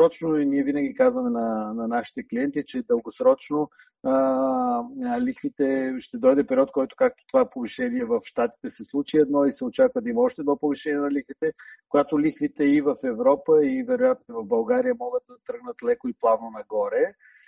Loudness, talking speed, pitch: -24 LUFS, 170 wpm, 240 Hz